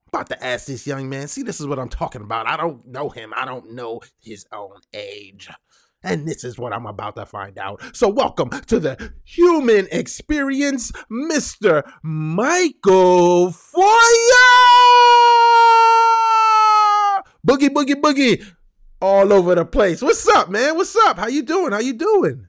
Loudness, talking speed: -15 LUFS, 155 wpm